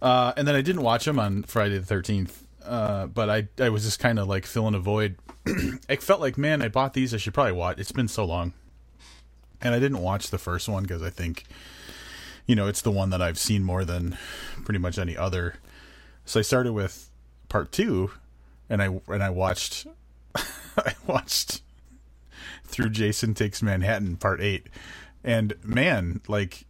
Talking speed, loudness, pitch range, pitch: 190 wpm, -26 LUFS, 90-115 Hz, 100 Hz